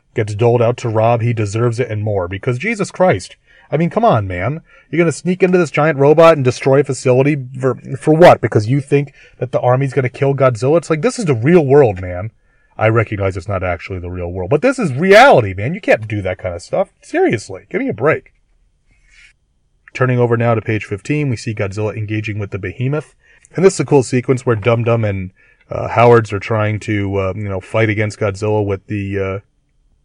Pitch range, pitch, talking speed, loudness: 105-145 Hz, 120 Hz, 220 wpm, -15 LUFS